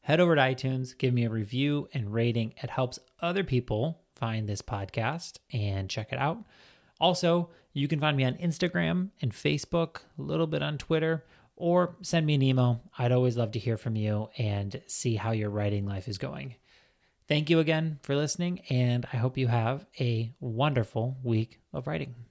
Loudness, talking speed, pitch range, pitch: -29 LUFS, 190 wpm, 115-160 Hz, 130 Hz